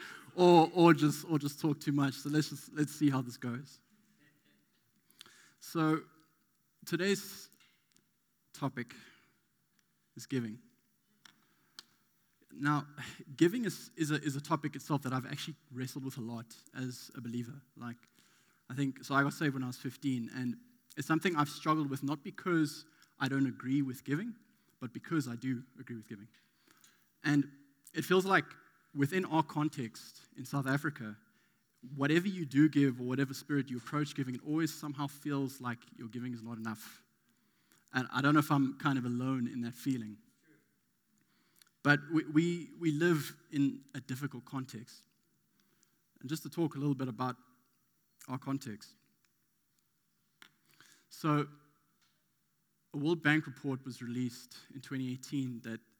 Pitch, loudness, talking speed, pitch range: 140 Hz, -34 LUFS, 150 wpm, 125-155 Hz